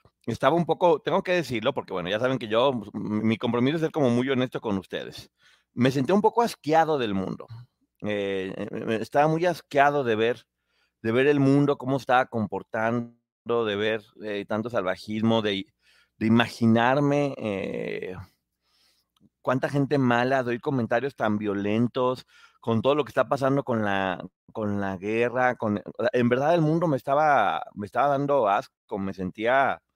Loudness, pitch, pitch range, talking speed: -25 LUFS, 120 Hz, 105-140 Hz, 160 wpm